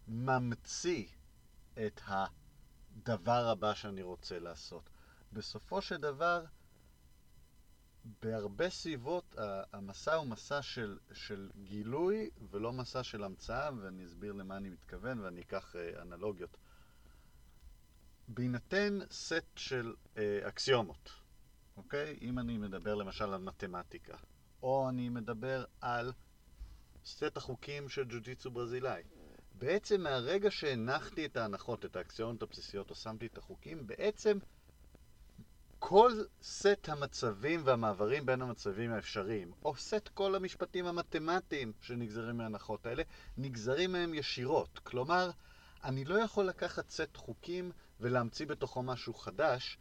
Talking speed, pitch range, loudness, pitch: 110 wpm, 100-145 Hz, -38 LUFS, 120 Hz